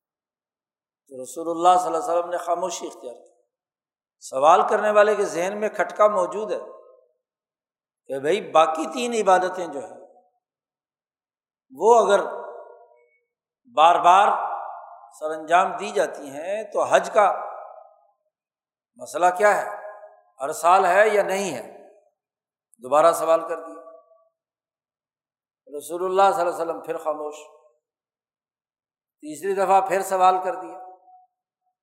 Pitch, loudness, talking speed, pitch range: 185 Hz, -21 LUFS, 125 wpm, 165-210 Hz